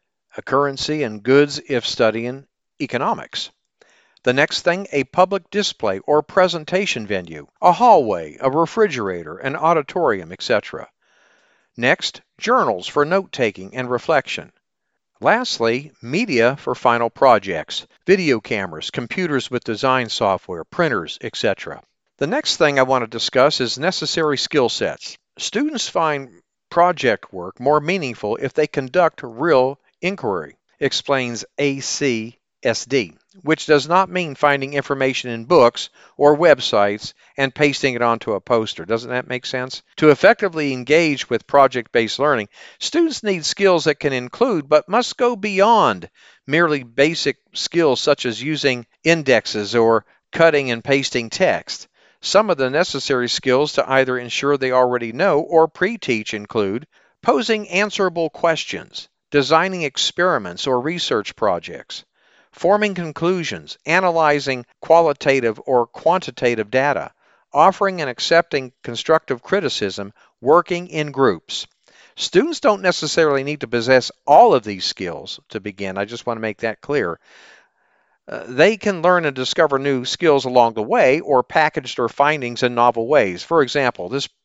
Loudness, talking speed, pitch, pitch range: -18 LUFS, 140 wpm, 140 Hz, 125-170 Hz